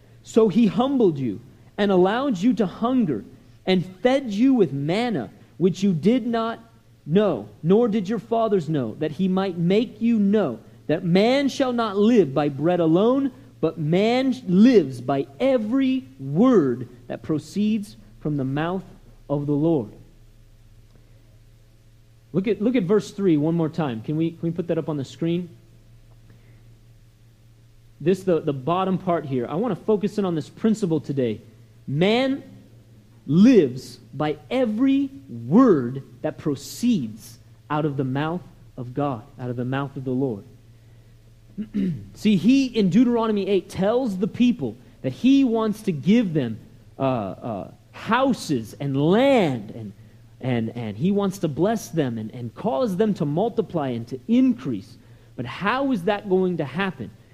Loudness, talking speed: -22 LUFS, 155 wpm